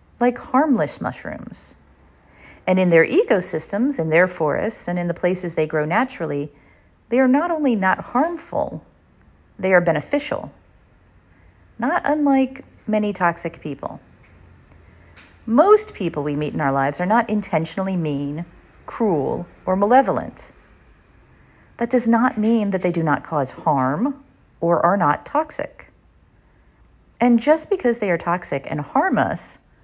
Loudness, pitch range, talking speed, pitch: -20 LUFS, 155-250 Hz, 135 wpm, 185 Hz